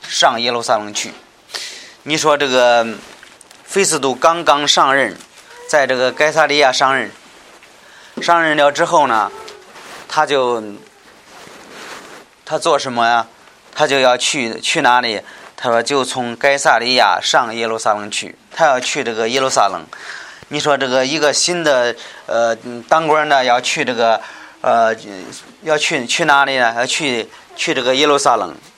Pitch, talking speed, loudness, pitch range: 140 Hz, 210 characters per minute, -15 LUFS, 120-155 Hz